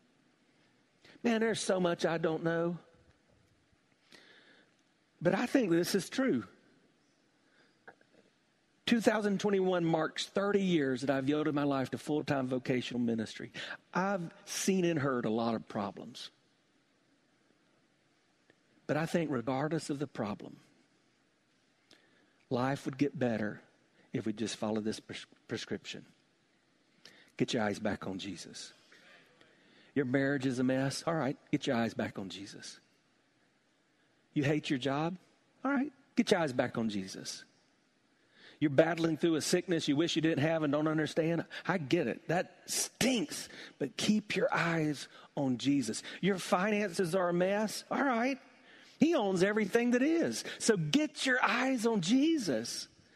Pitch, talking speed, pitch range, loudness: 165 Hz, 140 wpm, 140-210 Hz, -33 LUFS